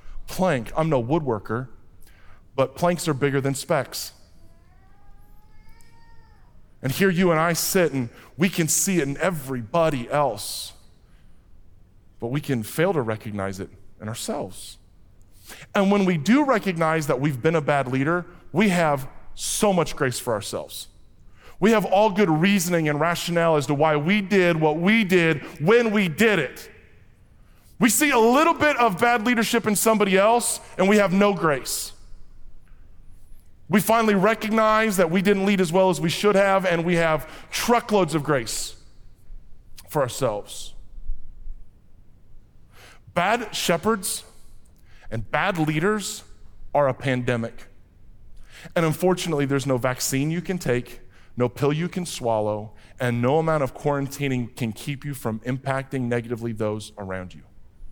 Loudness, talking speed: -22 LUFS, 145 wpm